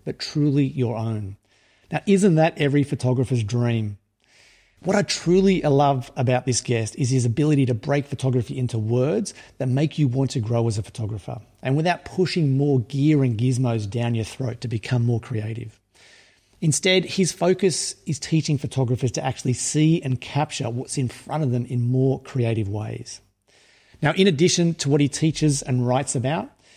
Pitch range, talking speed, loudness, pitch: 120-150 Hz, 175 wpm, -22 LUFS, 130 Hz